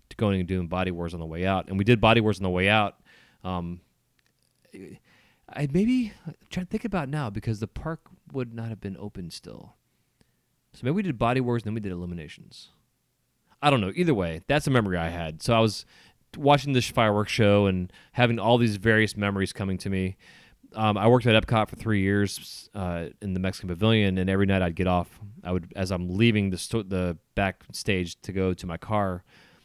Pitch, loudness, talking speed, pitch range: 100 Hz, -26 LUFS, 215 wpm, 90-115 Hz